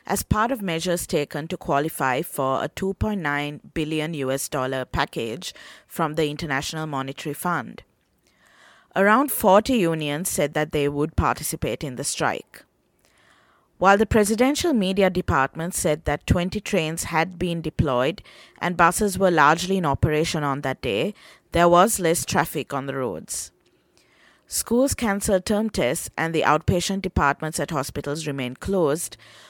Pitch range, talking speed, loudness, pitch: 145-190 Hz, 140 wpm, -23 LUFS, 160 Hz